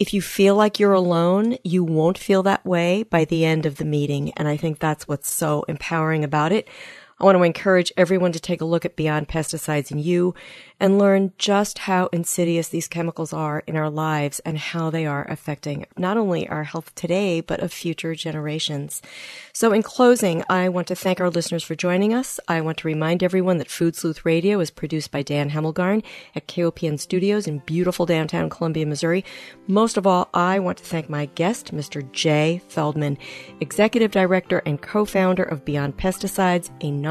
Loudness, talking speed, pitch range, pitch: -21 LUFS, 190 wpm, 155-185 Hz, 170 Hz